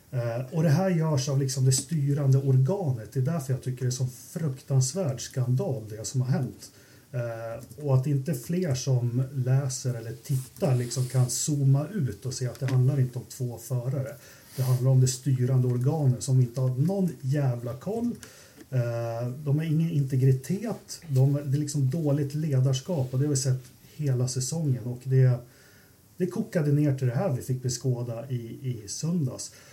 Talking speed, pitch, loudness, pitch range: 180 wpm, 130 Hz, -27 LUFS, 125-145 Hz